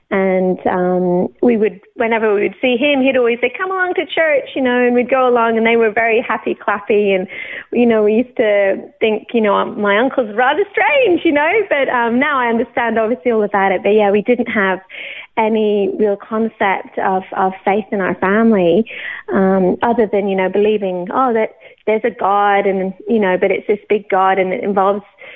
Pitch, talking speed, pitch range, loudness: 220 Hz, 210 wpm, 195-245 Hz, -15 LUFS